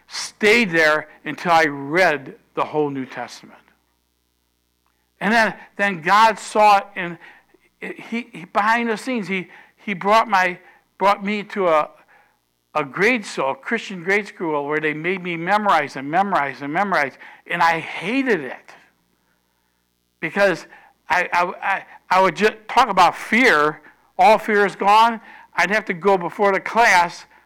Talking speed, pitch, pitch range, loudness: 155 wpm, 180 Hz, 145-210 Hz, -19 LUFS